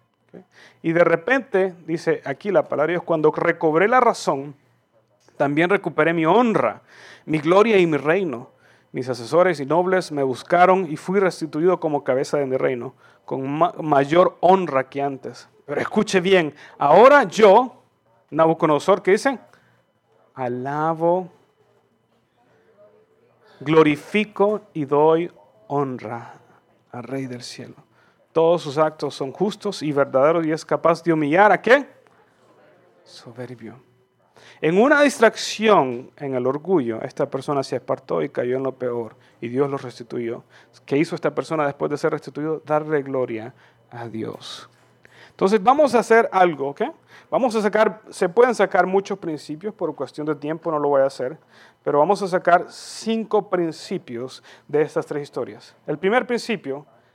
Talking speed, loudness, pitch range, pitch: 145 wpm, -20 LUFS, 135-185 Hz, 155 Hz